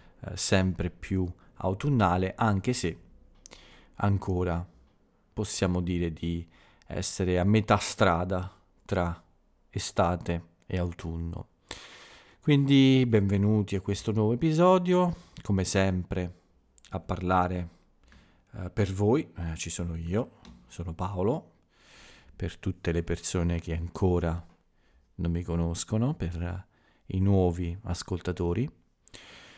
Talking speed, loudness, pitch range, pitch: 100 wpm, -28 LUFS, 85-100 Hz, 90 Hz